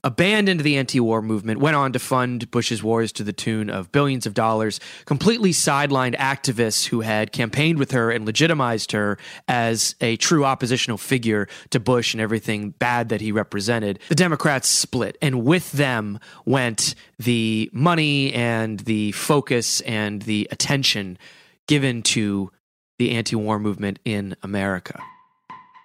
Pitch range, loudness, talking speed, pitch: 110-140 Hz, -21 LUFS, 145 wpm, 120 Hz